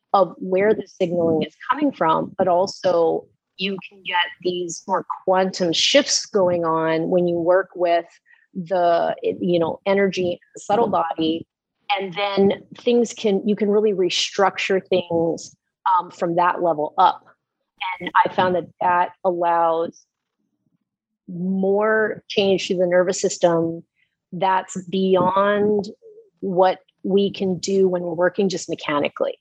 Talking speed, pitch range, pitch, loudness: 135 wpm, 175-200 Hz, 185 Hz, -20 LUFS